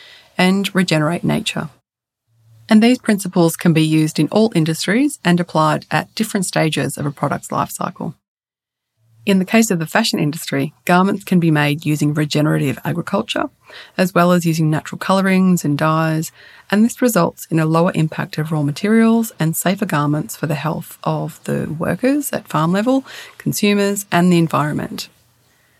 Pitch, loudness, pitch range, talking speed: 170 Hz, -17 LUFS, 155-200 Hz, 165 wpm